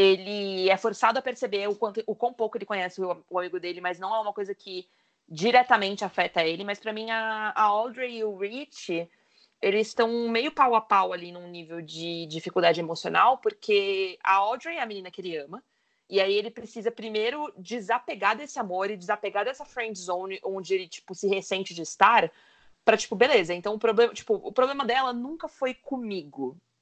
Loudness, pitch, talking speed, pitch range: -27 LUFS, 210 Hz, 195 wpm, 185-235 Hz